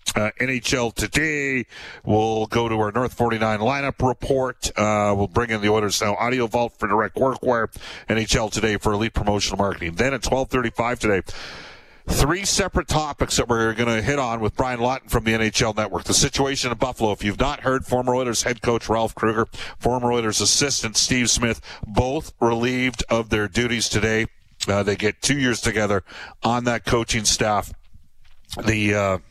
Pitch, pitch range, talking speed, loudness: 115 Hz, 105-125 Hz, 180 wpm, -21 LUFS